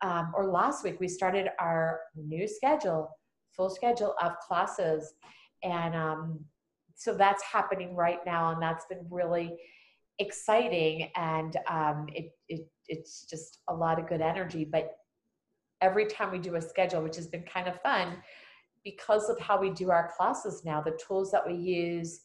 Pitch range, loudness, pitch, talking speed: 165-195 Hz, -31 LUFS, 175 Hz, 165 wpm